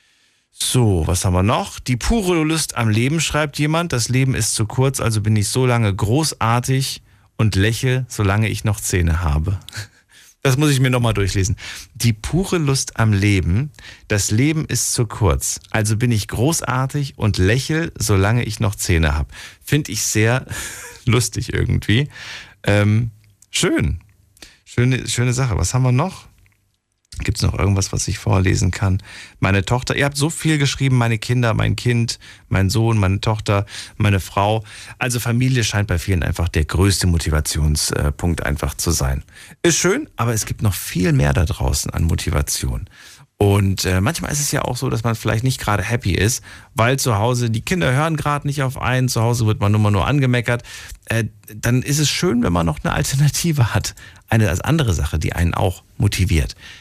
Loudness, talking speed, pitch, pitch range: -19 LUFS, 180 wpm, 110 Hz, 100-125 Hz